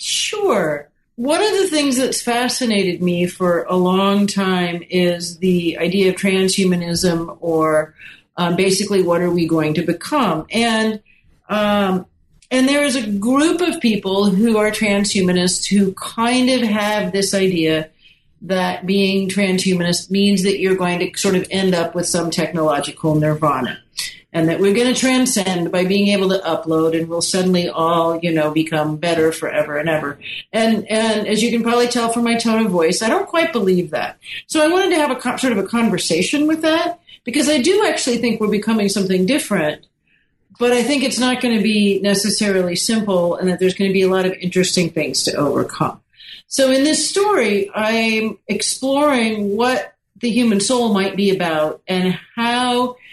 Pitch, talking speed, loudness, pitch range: 195 Hz, 180 wpm, -17 LUFS, 175-235 Hz